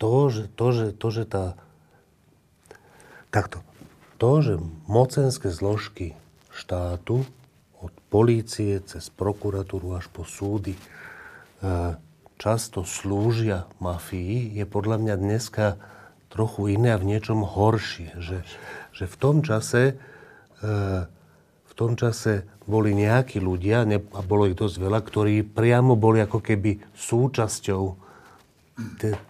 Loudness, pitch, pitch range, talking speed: -25 LUFS, 105 Hz, 95-115 Hz, 115 wpm